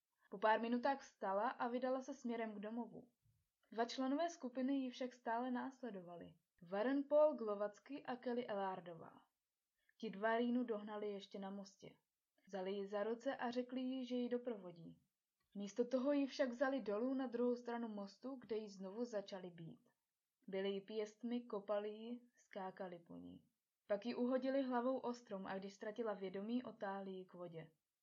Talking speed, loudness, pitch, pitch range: 165 wpm, -44 LUFS, 225 Hz, 200-250 Hz